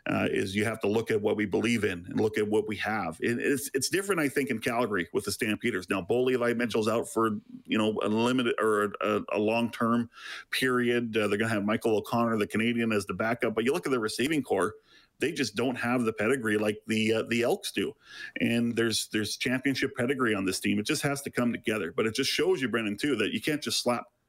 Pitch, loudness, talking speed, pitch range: 115 Hz, -28 LUFS, 245 wpm, 105-120 Hz